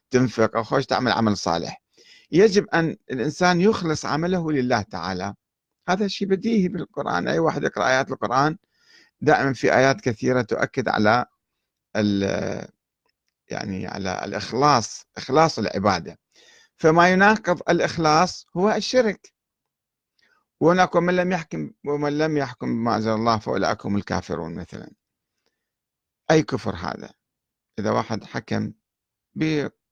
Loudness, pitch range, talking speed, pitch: -22 LUFS, 110-175 Hz, 115 wpm, 145 Hz